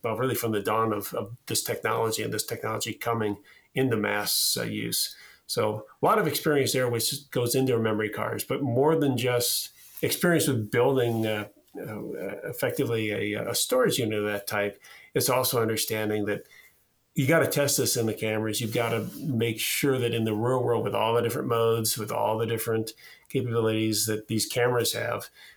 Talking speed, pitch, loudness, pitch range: 185 wpm, 115 Hz, -26 LUFS, 110-125 Hz